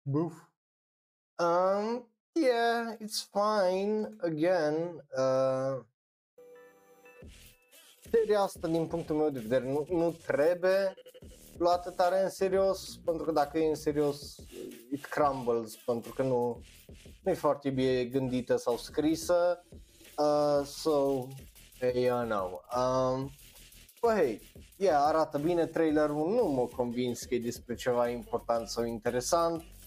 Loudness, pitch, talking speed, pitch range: -30 LUFS, 155 Hz, 125 wpm, 130-180 Hz